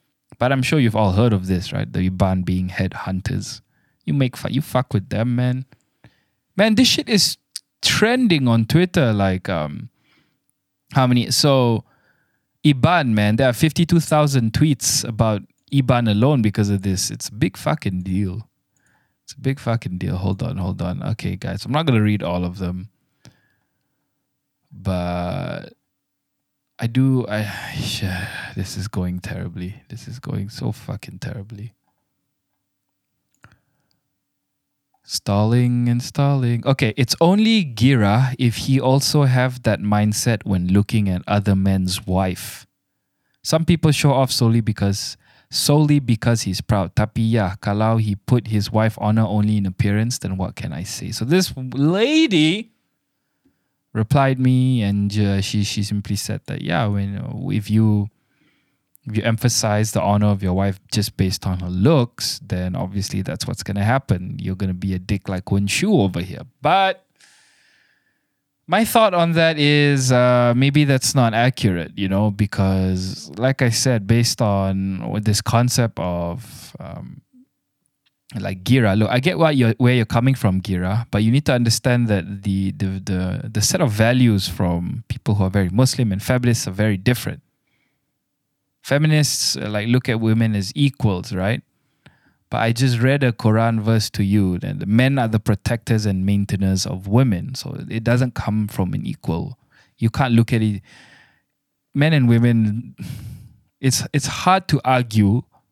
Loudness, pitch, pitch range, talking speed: -19 LUFS, 115 Hz, 100-135 Hz, 160 wpm